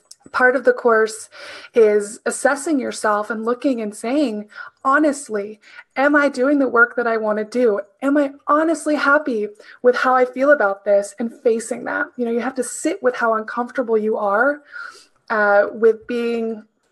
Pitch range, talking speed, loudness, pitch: 220-290 Hz, 175 wpm, -18 LUFS, 245 Hz